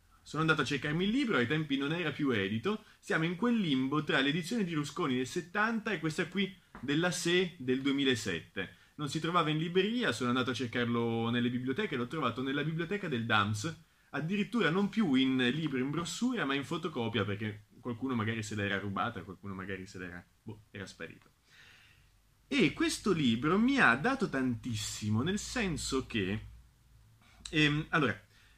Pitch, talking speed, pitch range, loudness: 135 Hz, 170 wpm, 115-175 Hz, -32 LUFS